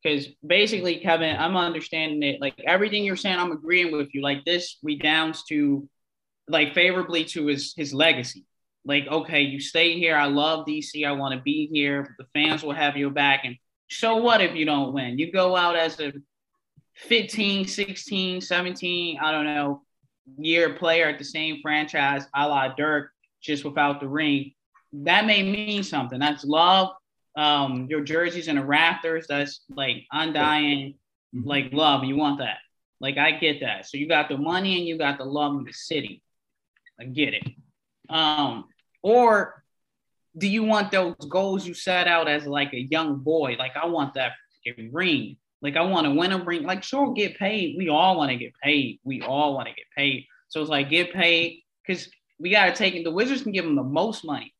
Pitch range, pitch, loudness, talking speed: 140-175 Hz, 155 Hz, -23 LUFS, 195 wpm